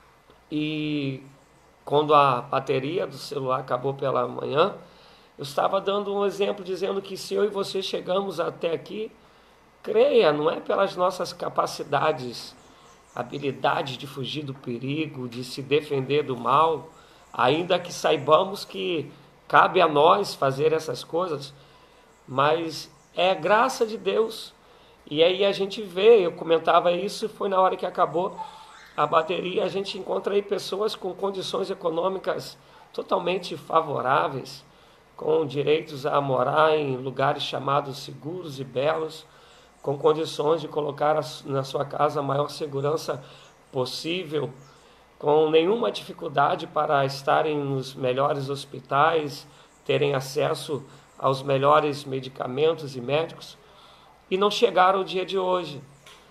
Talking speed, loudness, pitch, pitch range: 130 wpm, -25 LUFS, 155 Hz, 140-190 Hz